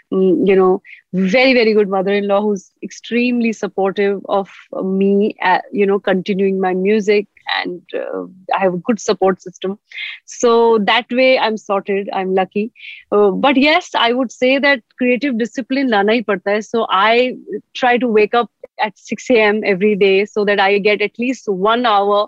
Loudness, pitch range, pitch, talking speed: -15 LUFS, 195-235 Hz, 210 Hz, 165 wpm